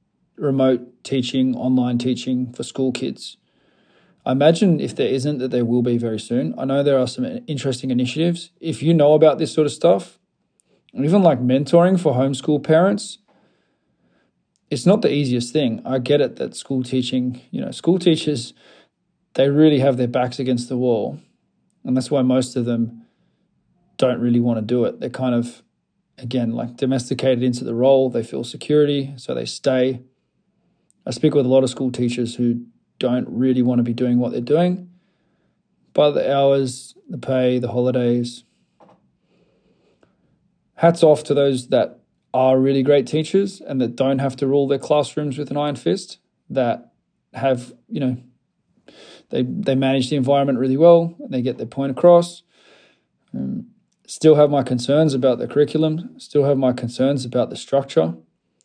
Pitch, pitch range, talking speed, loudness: 130 Hz, 125-145 Hz, 170 wpm, -19 LUFS